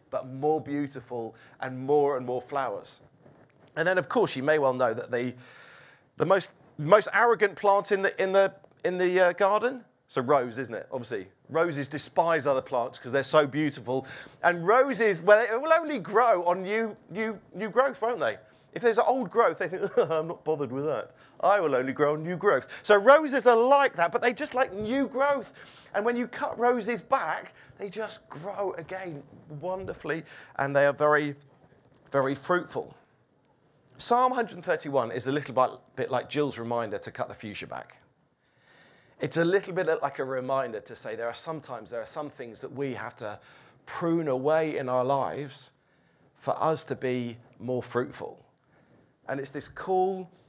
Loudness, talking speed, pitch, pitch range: -27 LUFS, 185 wpm, 155 Hz, 135-205 Hz